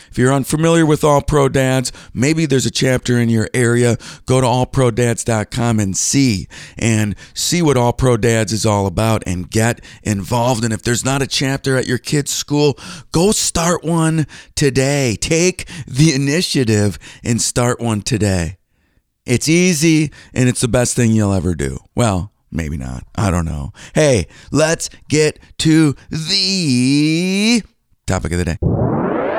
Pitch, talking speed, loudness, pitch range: 125 Hz, 155 wpm, -16 LUFS, 110-145 Hz